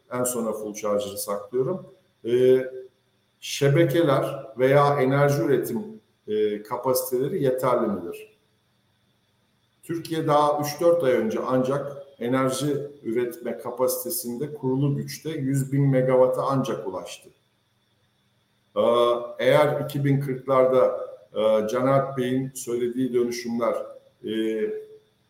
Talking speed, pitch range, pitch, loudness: 90 wpm, 125-145 Hz, 130 Hz, -24 LUFS